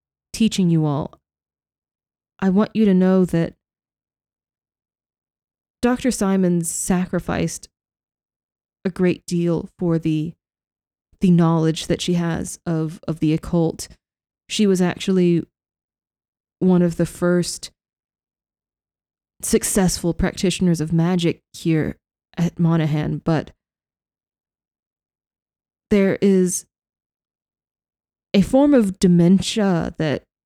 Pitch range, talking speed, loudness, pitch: 160-190 Hz, 95 wpm, -20 LUFS, 175 Hz